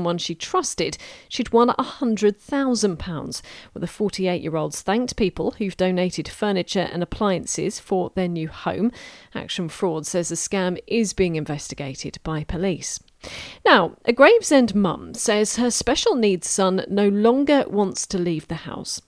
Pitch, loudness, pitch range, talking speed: 190 Hz, -22 LUFS, 170-230 Hz, 150 wpm